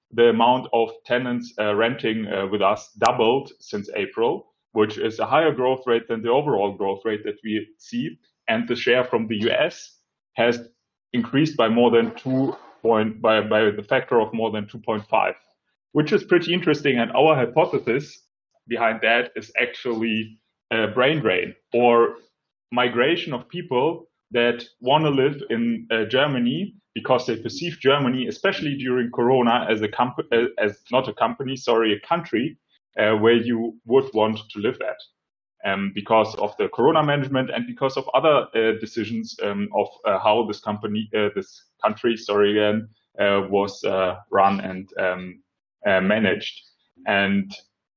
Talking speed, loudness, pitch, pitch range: 160 wpm, -22 LUFS, 115 Hz, 110-130 Hz